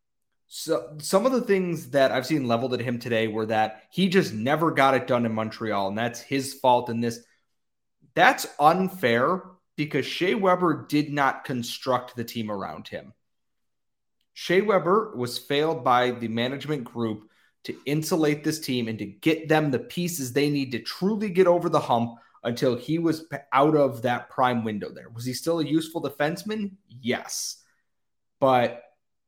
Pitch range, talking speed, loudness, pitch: 120-160 Hz, 170 wpm, -25 LUFS, 135 Hz